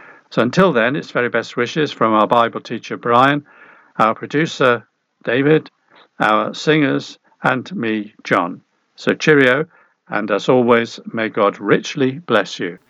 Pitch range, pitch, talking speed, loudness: 110-145 Hz, 120 Hz, 140 wpm, -17 LUFS